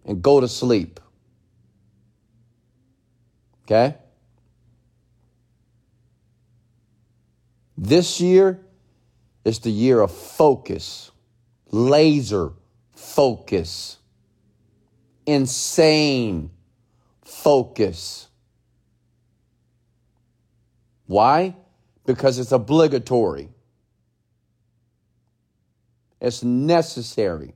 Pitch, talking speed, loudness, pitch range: 120 Hz, 50 wpm, -19 LUFS, 115-125 Hz